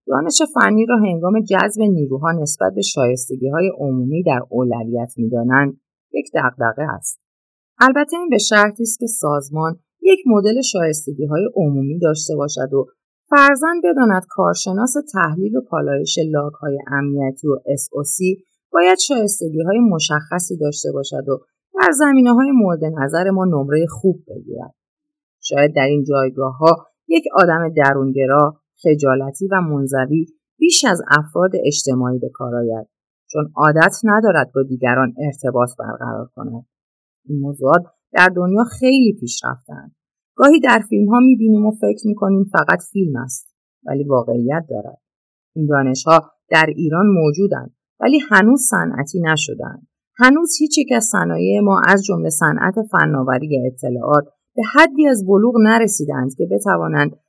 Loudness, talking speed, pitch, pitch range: -16 LUFS, 140 wpm, 160 Hz, 140-215 Hz